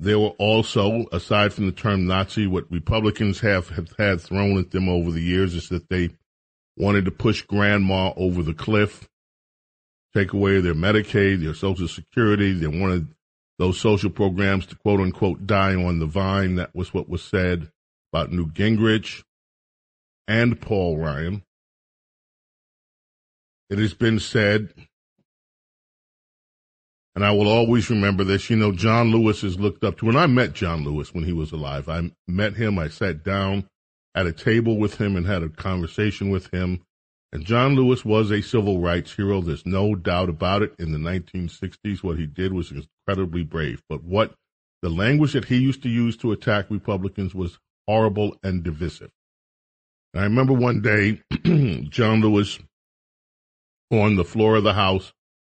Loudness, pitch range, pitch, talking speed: -22 LUFS, 90-105 Hz, 95 Hz, 165 wpm